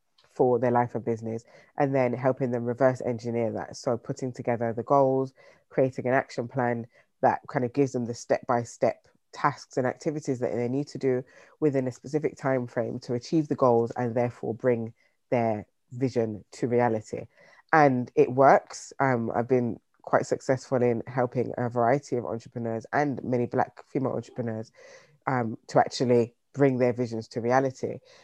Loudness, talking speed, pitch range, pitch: -27 LUFS, 170 wpm, 120-135 Hz, 125 Hz